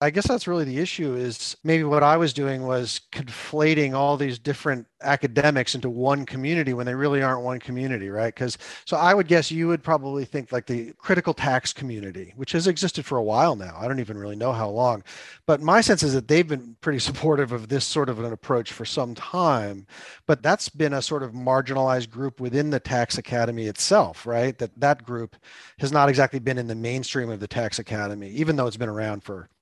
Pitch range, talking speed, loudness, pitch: 120-145 Hz, 220 wpm, -24 LUFS, 130 Hz